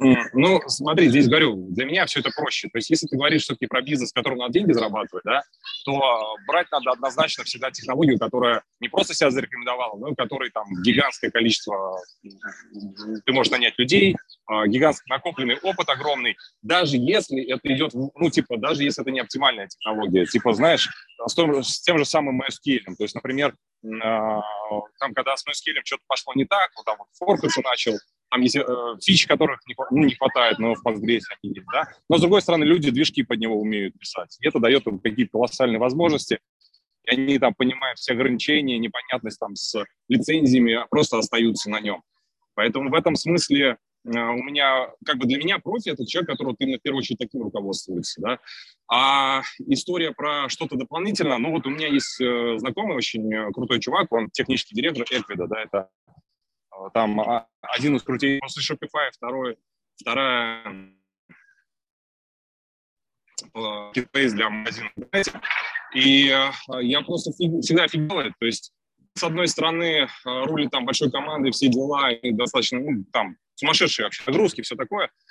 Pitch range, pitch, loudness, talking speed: 115-150 Hz, 130 Hz, -22 LUFS, 165 wpm